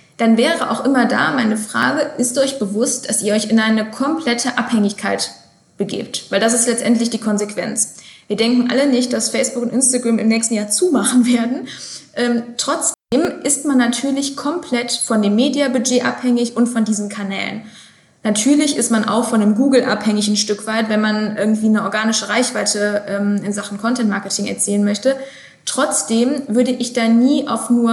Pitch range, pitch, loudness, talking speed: 215-250 Hz, 230 Hz, -17 LUFS, 175 wpm